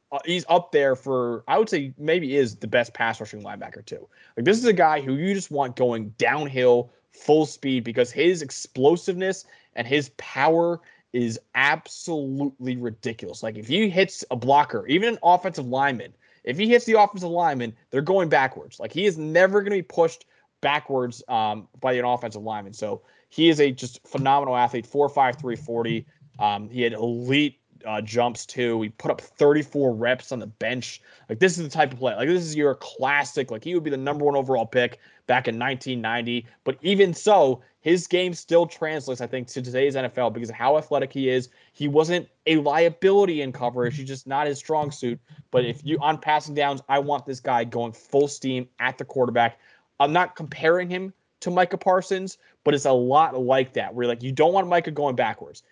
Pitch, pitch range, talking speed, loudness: 140 Hz, 125-160 Hz, 200 wpm, -23 LUFS